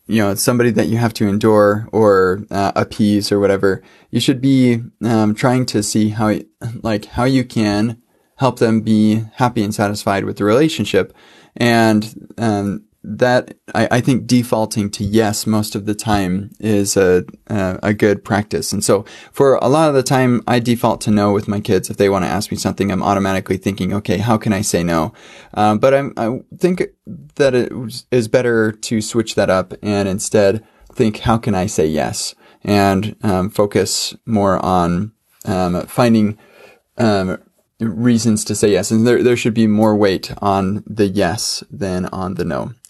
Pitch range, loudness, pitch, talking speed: 100-115 Hz, -16 LUFS, 110 Hz, 185 wpm